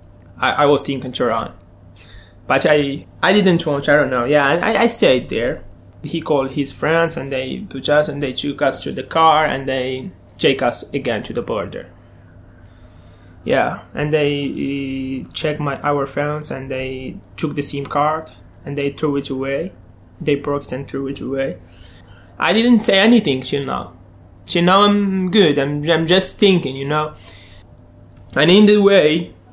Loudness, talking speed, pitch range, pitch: -17 LUFS, 175 wpm, 100-155 Hz, 140 Hz